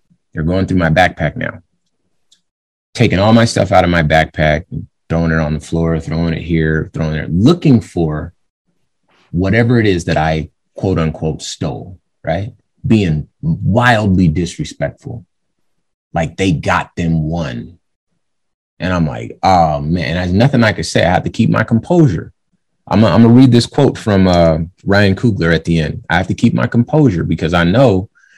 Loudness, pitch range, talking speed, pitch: -14 LUFS, 80-115 Hz, 175 wpm, 90 Hz